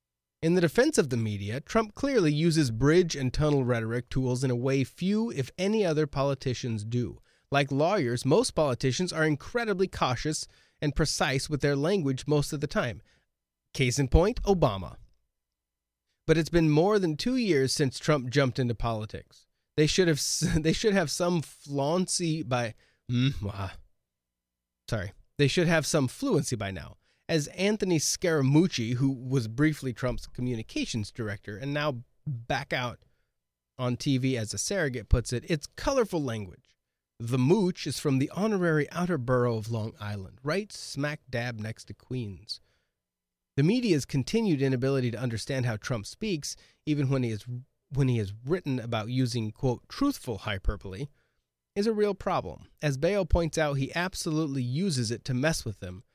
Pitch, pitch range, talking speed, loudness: 135 Hz, 115-160 Hz, 155 wpm, -28 LUFS